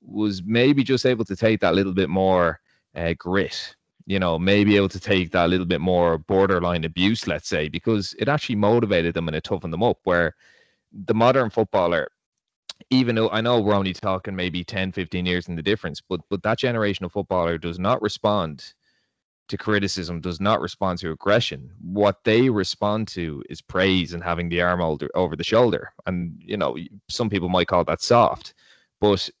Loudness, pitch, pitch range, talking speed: -22 LUFS, 95 Hz, 90-105 Hz, 190 wpm